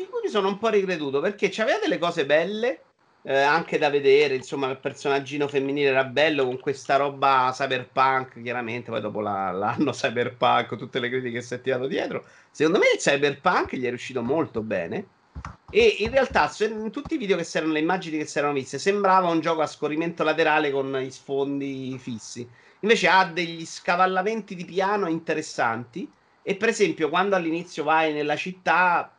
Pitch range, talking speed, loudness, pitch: 135-195 Hz, 180 wpm, -24 LUFS, 155 Hz